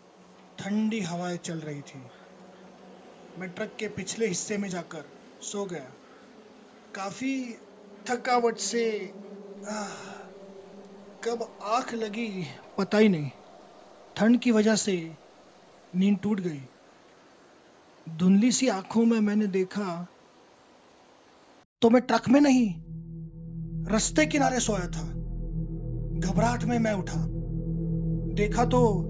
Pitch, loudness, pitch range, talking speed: 200 Hz, -27 LUFS, 165-220 Hz, 105 wpm